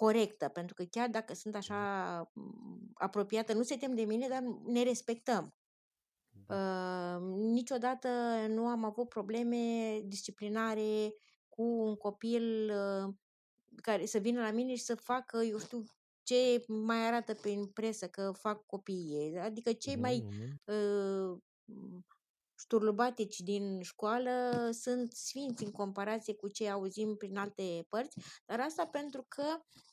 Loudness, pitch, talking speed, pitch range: -37 LUFS, 220 Hz, 135 wpm, 200-235 Hz